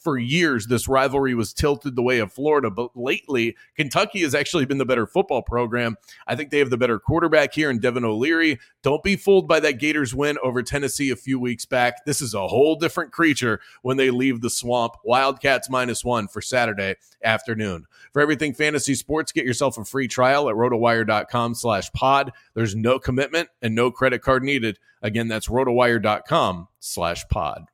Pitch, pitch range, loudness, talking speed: 125 Hz, 115-140 Hz, -21 LUFS, 180 wpm